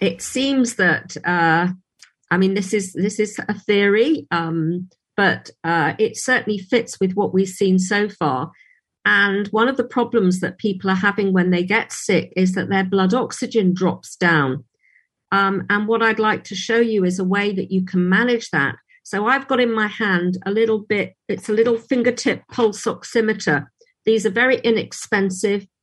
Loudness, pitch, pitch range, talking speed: -19 LUFS, 205 Hz, 185-225 Hz, 185 wpm